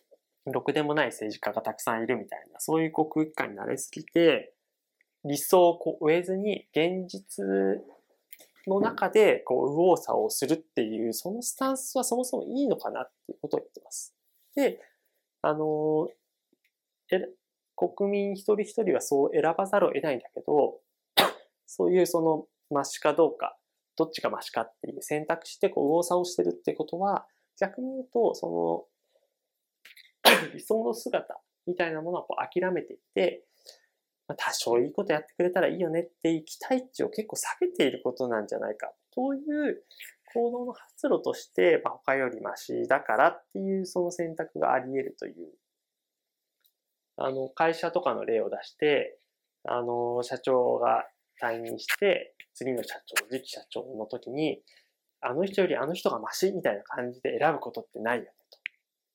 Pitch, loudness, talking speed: 180 Hz, -28 LUFS, 320 characters per minute